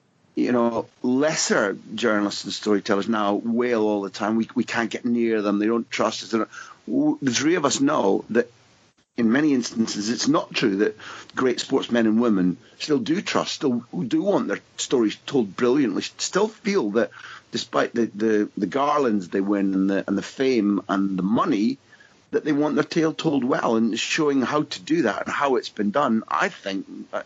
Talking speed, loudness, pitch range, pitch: 190 wpm, -23 LUFS, 105-150 Hz, 115 Hz